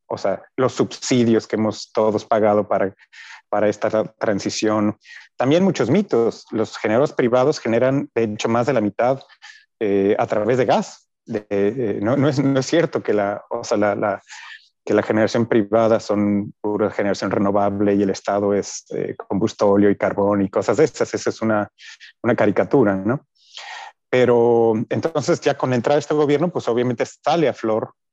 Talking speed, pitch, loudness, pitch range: 180 wpm, 110 Hz, -20 LUFS, 105-125 Hz